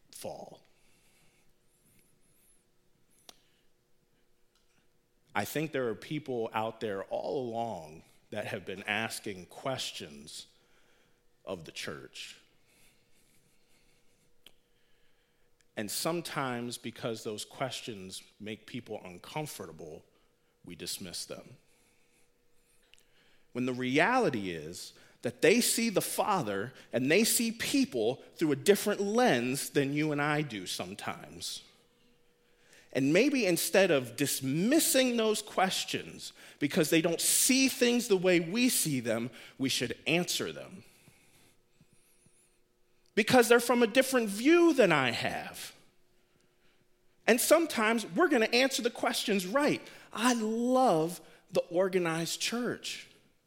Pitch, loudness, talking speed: 170 Hz, -30 LUFS, 105 wpm